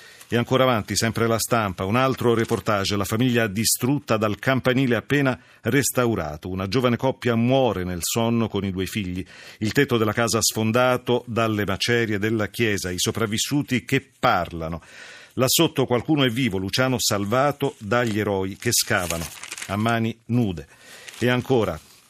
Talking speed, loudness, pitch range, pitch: 150 wpm, -22 LUFS, 105-125 Hz, 115 Hz